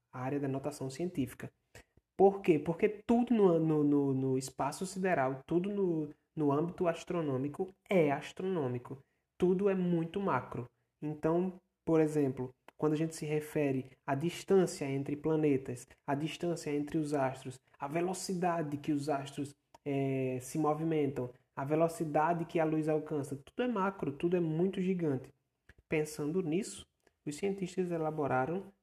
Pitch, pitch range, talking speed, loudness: 155 Hz, 140-175 Hz, 145 wpm, -34 LUFS